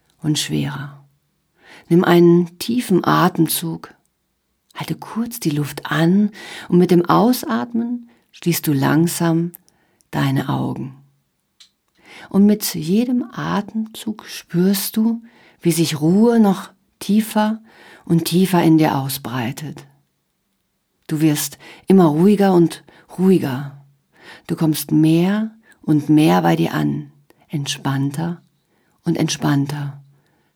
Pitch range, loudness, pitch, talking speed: 145-195 Hz, -18 LUFS, 165 Hz, 105 wpm